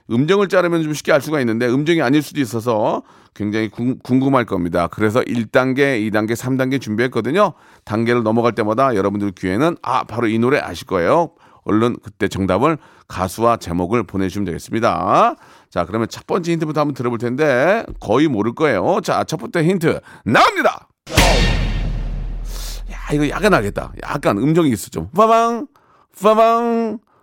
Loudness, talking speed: -17 LUFS, 340 characters per minute